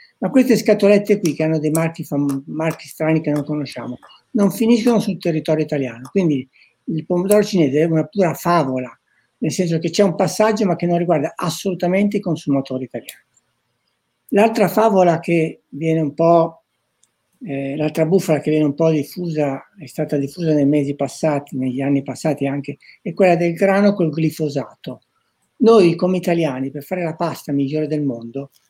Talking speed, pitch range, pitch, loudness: 170 wpm, 145-180 Hz, 160 Hz, -18 LUFS